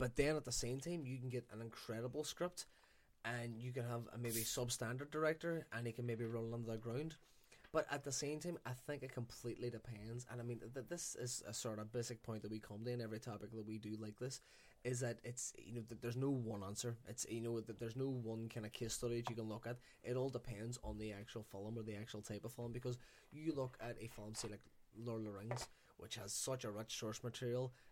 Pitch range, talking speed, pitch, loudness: 115-125 Hz, 255 wpm, 120 Hz, -46 LUFS